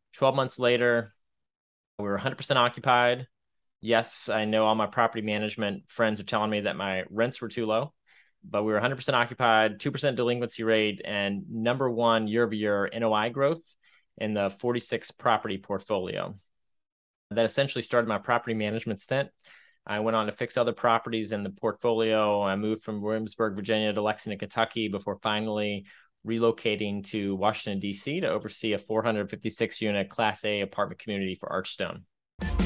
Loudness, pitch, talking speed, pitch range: -28 LUFS, 110 Hz, 155 wpm, 105-120 Hz